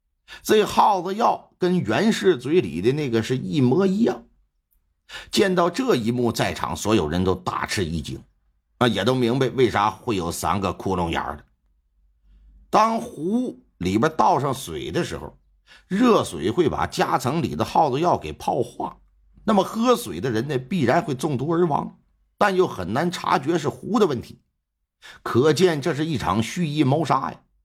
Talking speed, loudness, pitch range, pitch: 235 characters per minute, -22 LUFS, 110-180 Hz, 140 Hz